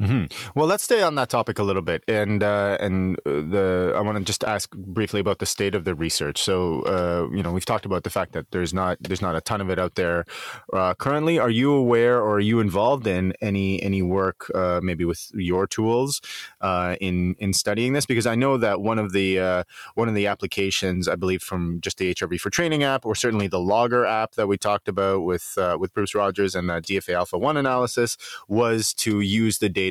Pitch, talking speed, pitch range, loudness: 100 Hz, 230 wpm, 95-115 Hz, -23 LUFS